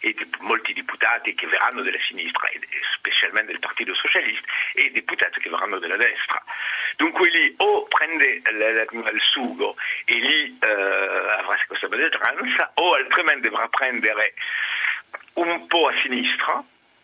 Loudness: -21 LUFS